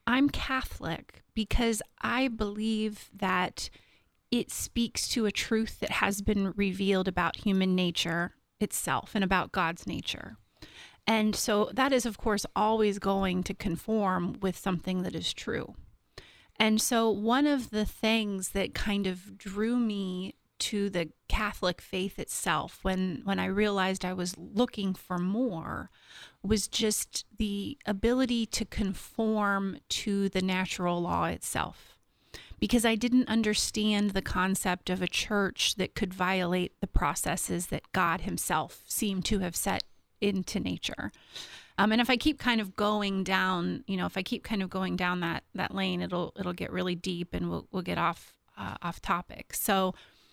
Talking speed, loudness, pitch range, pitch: 155 wpm, -30 LUFS, 185-220 Hz, 200 Hz